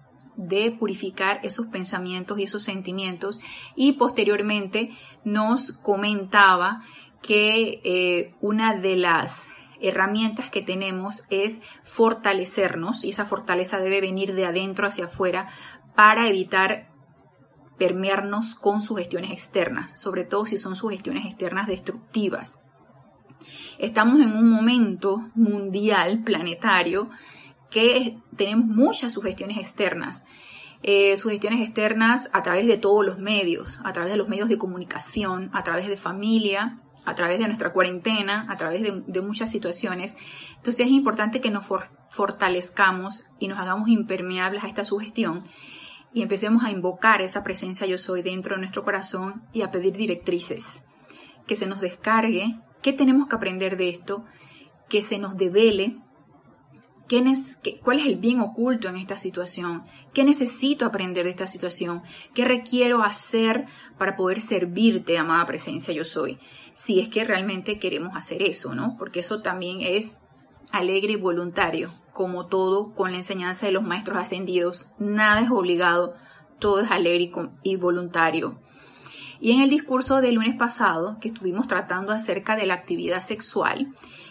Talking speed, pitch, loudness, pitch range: 140 wpm, 200 Hz, -23 LUFS, 185-220 Hz